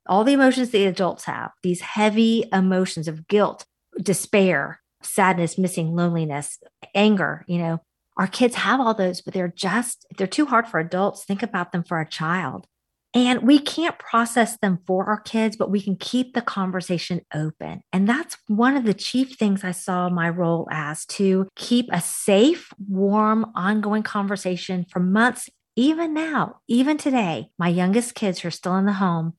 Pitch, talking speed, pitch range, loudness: 195 Hz, 165 wpm, 180-230 Hz, -22 LUFS